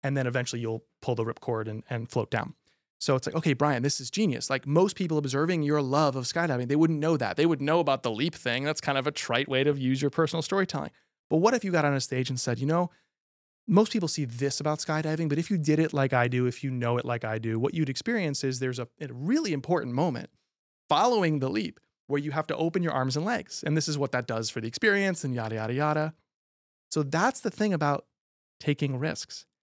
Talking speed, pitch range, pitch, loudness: 250 wpm, 125-160 Hz, 145 Hz, -28 LUFS